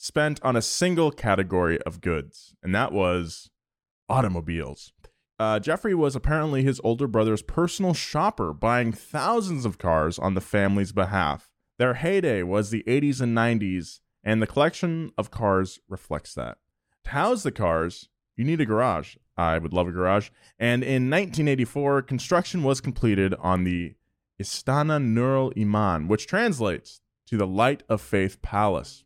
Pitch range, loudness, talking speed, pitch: 95-140 Hz, -25 LUFS, 155 wpm, 115 Hz